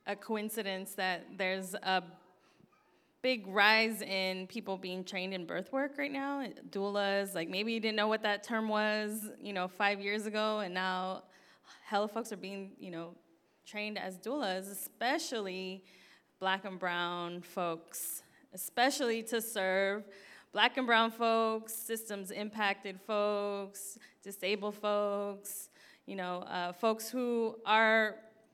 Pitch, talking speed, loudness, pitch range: 205 Hz, 135 wpm, -34 LUFS, 190-220 Hz